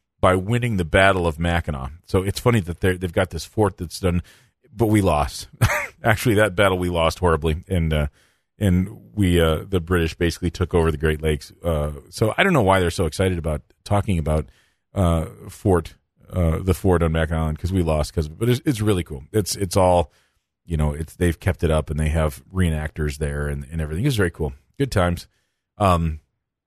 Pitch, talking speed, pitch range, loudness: 85 Hz, 205 wpm, 80-95 Hz, -22 LUFS